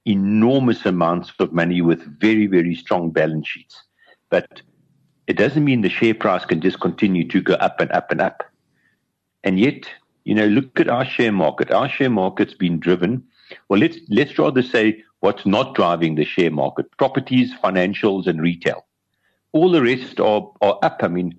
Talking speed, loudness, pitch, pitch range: 180 wpm, -19 LUFS, 95 Hz, 85-115 Hz